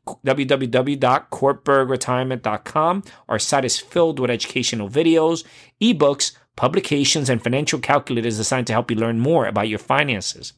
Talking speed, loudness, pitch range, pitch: 125 wpm, -20 LUFS, 120-155 Hz, 135 Hz